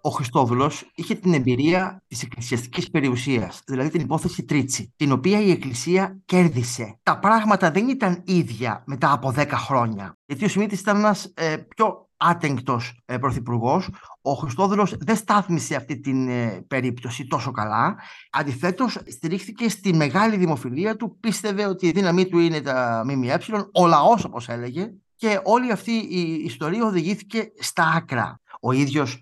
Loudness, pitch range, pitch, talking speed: -22 LUFS, 130-195 Hz, 165 Hz, 150 wpm